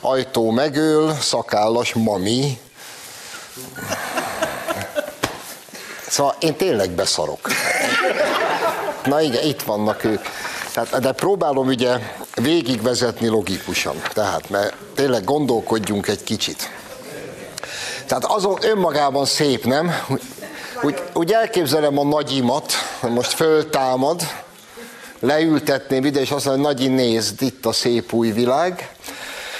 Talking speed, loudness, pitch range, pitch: 95 wpm, -20 LUFS, 115-145 Hz, 130 Hz